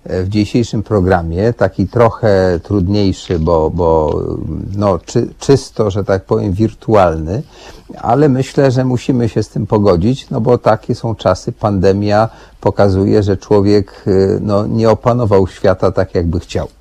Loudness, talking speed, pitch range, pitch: -14 LUFS, 140 wpm, 95-120 Hz, 105 Hz